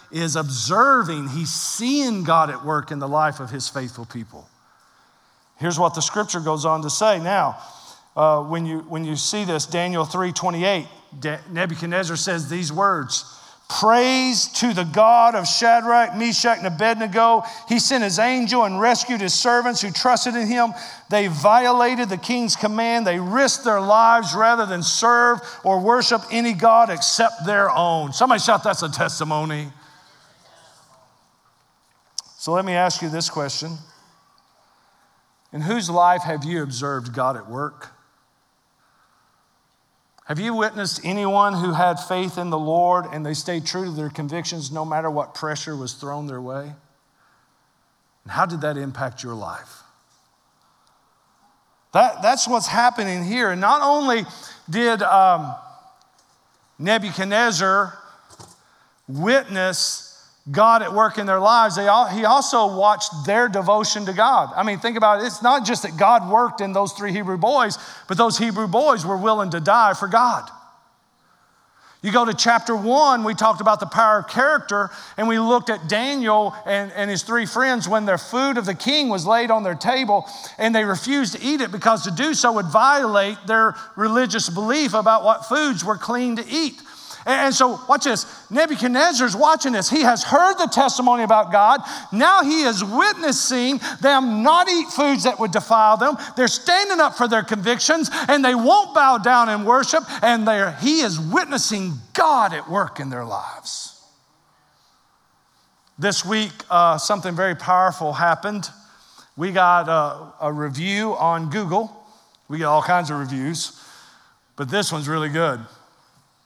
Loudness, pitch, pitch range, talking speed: -19 LUFS, 210 Hz, 170-235 Hz, 160 wpm